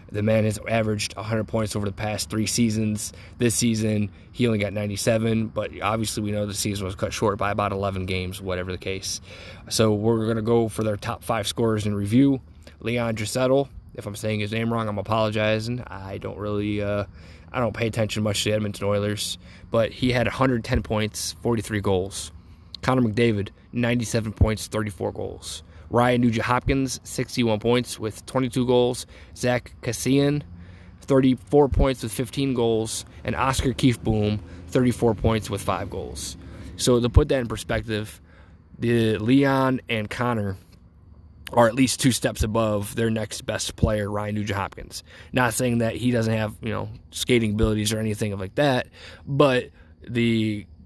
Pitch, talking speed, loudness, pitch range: 110 Hz, 170 wpm, -24 LUFS, 95-120 Hz